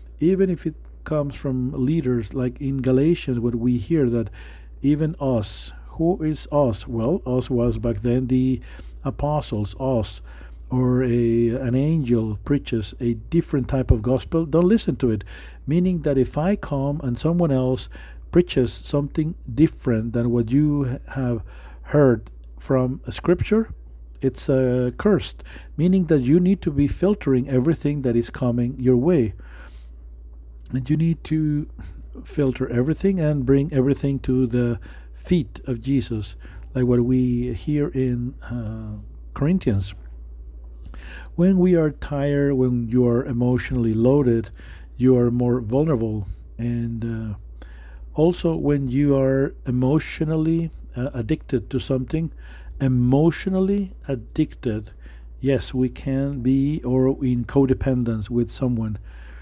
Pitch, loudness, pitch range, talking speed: 130 Hz, -22 LUFS, 115-145 Hz, 130 wpm